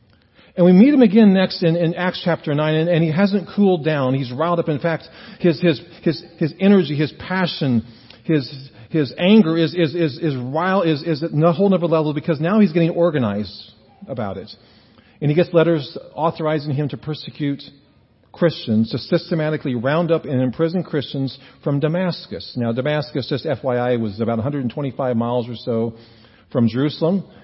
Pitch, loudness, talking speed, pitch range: 155 Hz, -19 LUFS, 175 wpm, 130-170 Hz